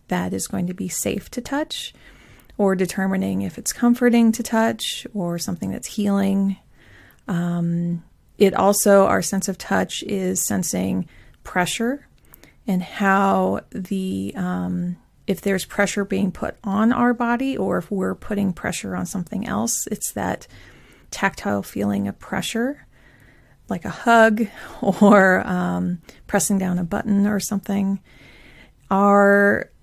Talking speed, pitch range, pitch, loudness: 135 wpm, 180-210 Hz, 195 Hz, -21 LUFS